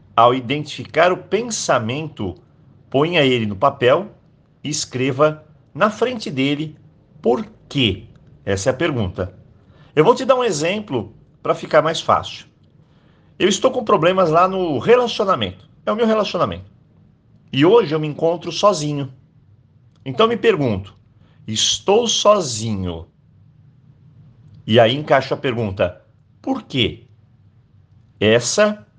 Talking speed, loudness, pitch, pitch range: 125 wpm, -18 LUFS, 140 Hz, 115-165 Hz